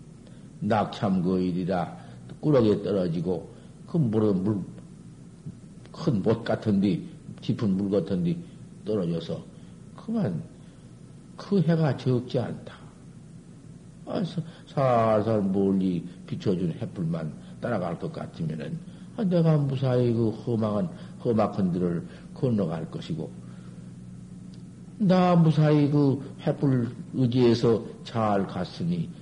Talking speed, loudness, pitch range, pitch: 210 characters per minute, -26 LUFS, 100-165 Hz, 130 Hz